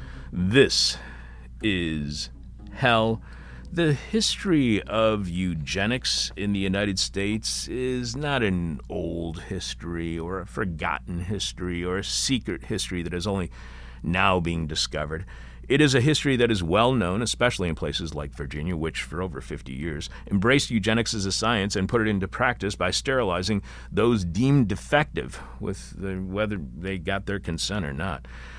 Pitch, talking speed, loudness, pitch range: 95 Hz, 150 wpm, -25 LUFS, 80-110 Hz